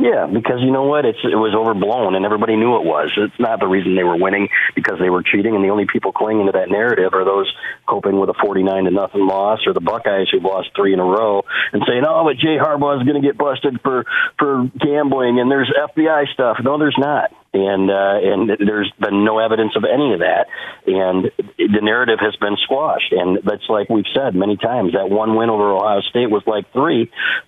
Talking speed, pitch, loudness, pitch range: 225 wpm, 105 Hz, -16 LUFS, 95-125 Hz